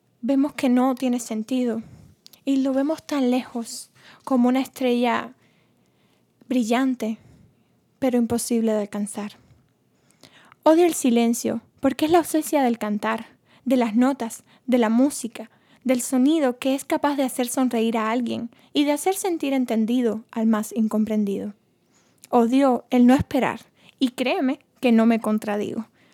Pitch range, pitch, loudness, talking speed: 225-270 Hz, 245 Hz, -22 LUFS, 140 wpm